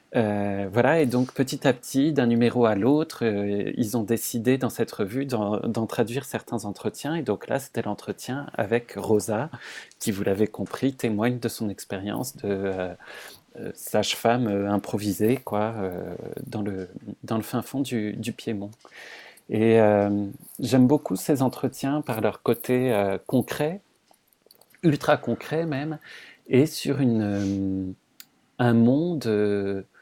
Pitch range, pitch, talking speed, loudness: 105-135 Hz, 115 Hz, 150 wpm, -25 LUFS